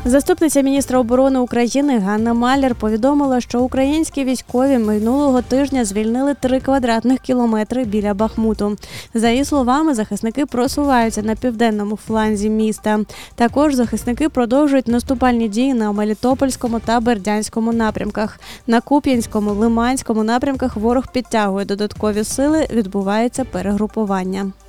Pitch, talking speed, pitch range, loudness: 240 Hz, 115 wpm, 215-265 Hz, -17 LUFS